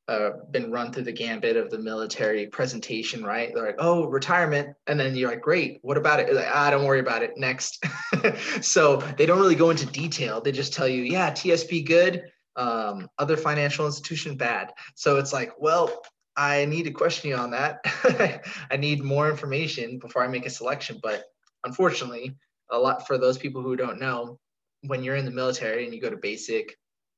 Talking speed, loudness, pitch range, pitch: 200 wpm, -25 LUFS, 130-165 Hz, 145 Hz